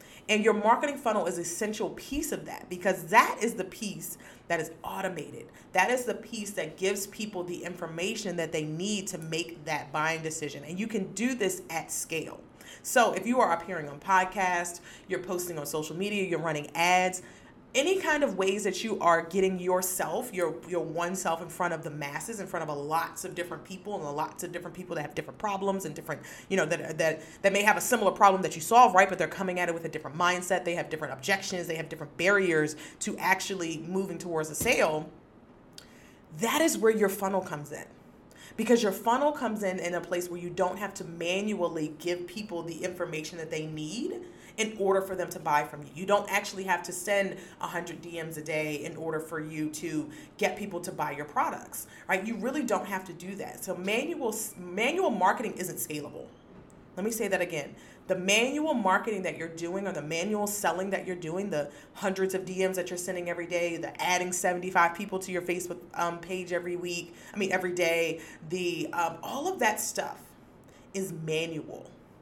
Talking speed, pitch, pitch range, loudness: 210 wpm, 180 Hz, 165-195 Hz, -30 LUFS